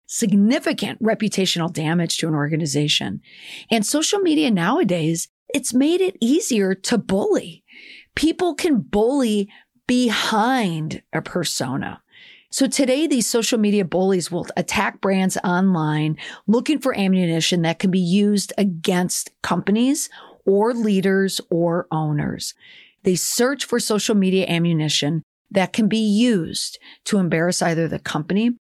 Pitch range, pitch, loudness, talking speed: 175-240 Hz, 200 Hz, -20 LUFS, 125 wpm